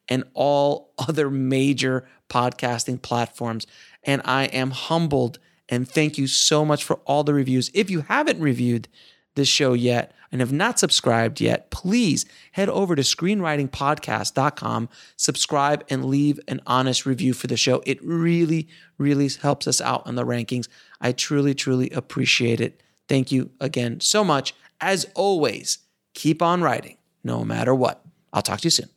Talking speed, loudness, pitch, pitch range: 160 wpm, -22 LUFS, 135 Hz, 125-155 Hz